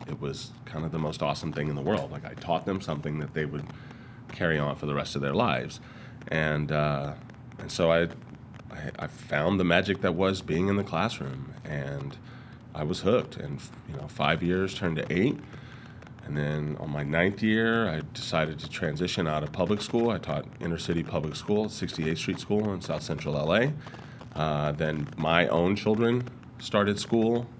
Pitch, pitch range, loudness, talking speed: 85 Hz, 75-110 Hz, -29 LUFS, 195 wpm